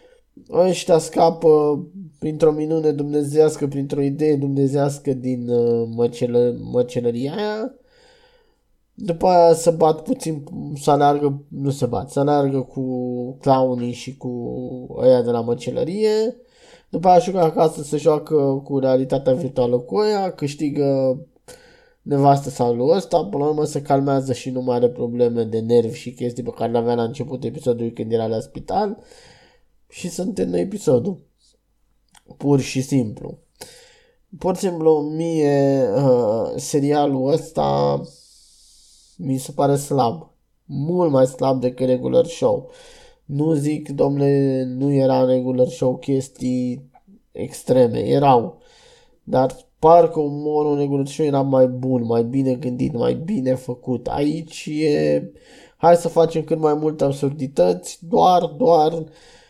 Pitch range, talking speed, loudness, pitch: 125-160 Hz, 135 wpm, -19 LUFS, 140 Hz